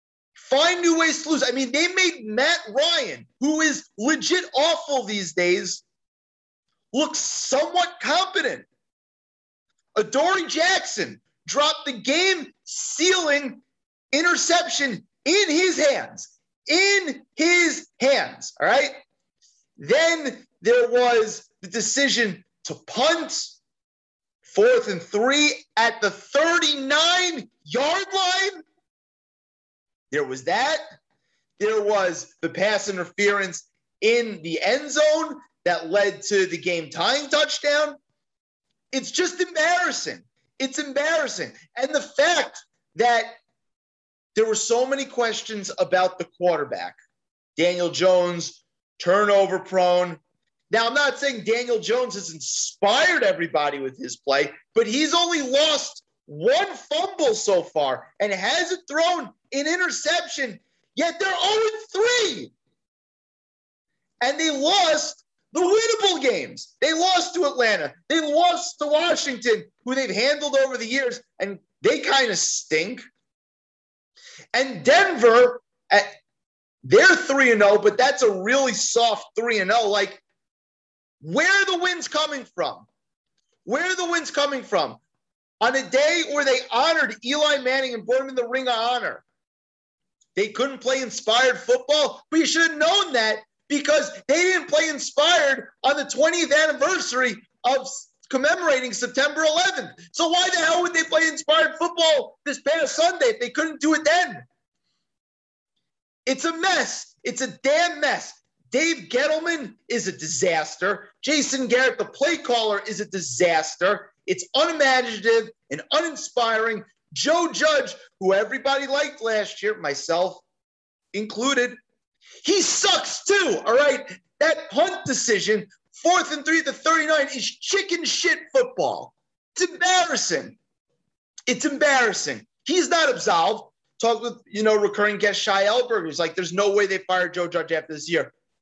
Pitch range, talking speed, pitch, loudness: 215-325 Hz, 130 wpm, 275 Hz, -21 LUFS